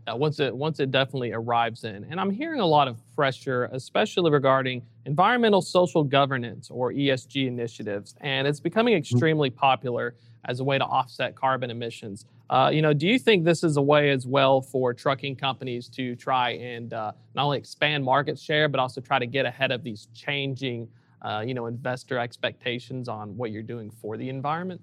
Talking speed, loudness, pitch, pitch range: 195 wpm, -25 LUFS, 130 Hz, 120-145 Hz